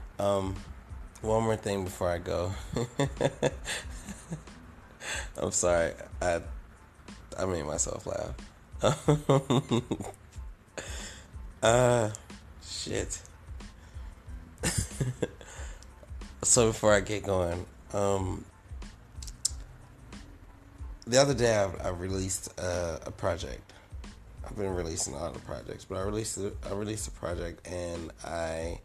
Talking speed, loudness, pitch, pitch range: 100 wpm, -30 LUFS, 95 Hz, 80-105 Hz